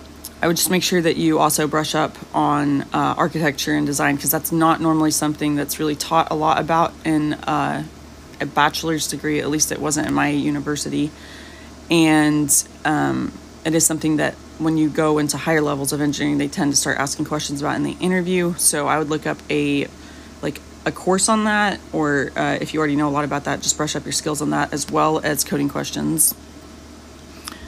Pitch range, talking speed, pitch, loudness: 145-160 Hz, 205 wpm, 150 Hz, -19 LUFS